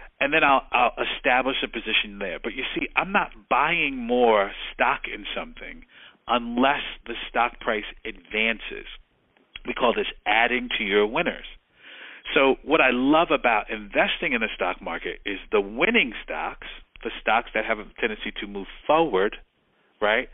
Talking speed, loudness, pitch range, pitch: 160 wpm, -23 LUFS, 105-130 Hz, 115 Hz